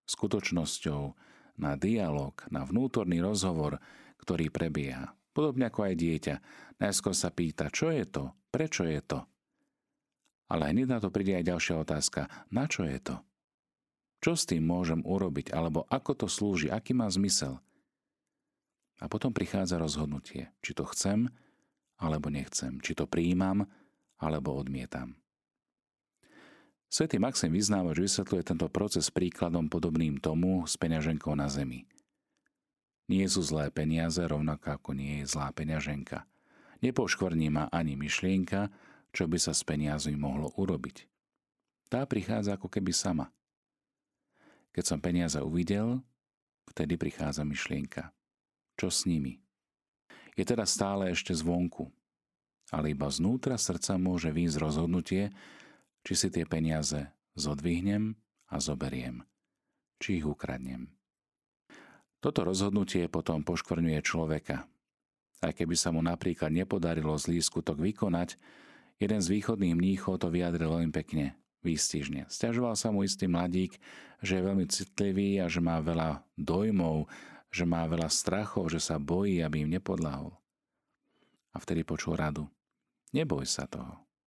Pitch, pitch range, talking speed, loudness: 85 Hz, 75-95 Hz, 130 wpm, -32 LUFS